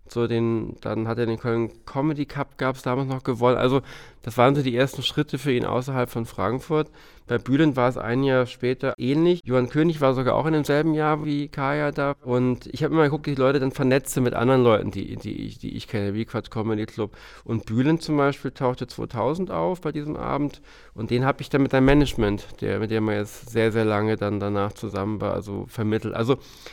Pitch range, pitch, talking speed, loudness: 115-140 Hz, 125 Hz, 230 wpm, -24 LUFS